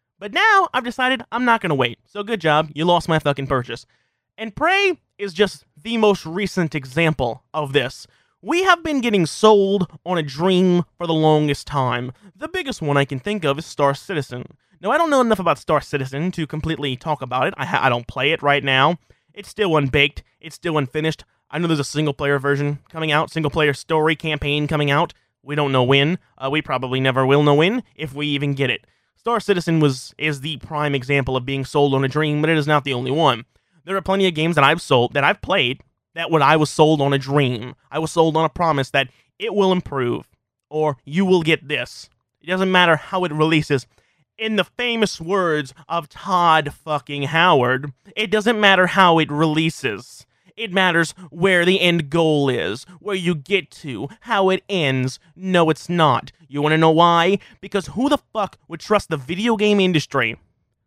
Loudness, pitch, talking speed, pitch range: -19 LUFS, 155 Hz, 210 wpm, 140-185 Hz